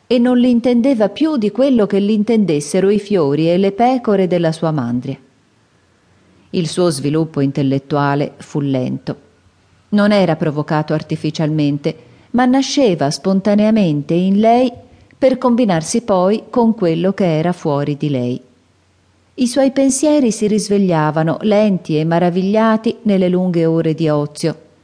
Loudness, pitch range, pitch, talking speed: -15 LUFS, 150-215 Hz, 175 Hz, 135 wpm